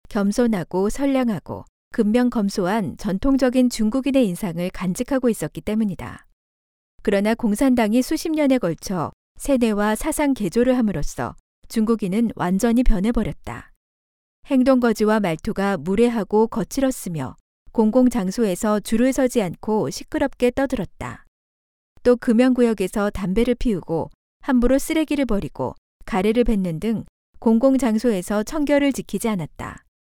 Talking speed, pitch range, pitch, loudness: 305 characters per minute, 195-250 Hz, 225 Hz, -21 LUFS